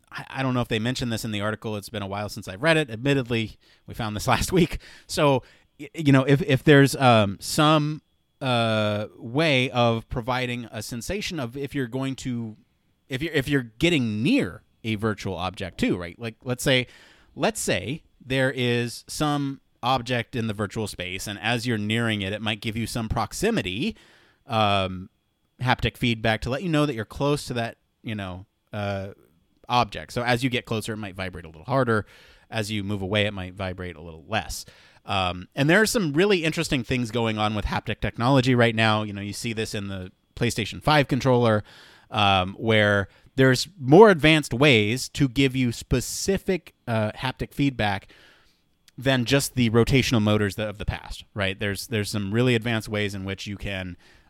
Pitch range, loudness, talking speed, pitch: 105-130 Hz, -24 LUFS, 190 wpm, 115 Hz